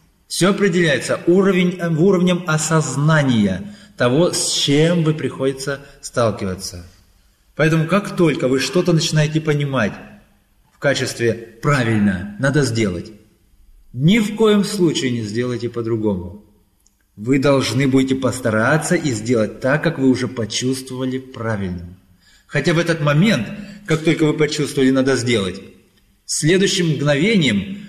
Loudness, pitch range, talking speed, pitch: -18 LUFS, 115-170 Hz, 115 wpm, 140 Hz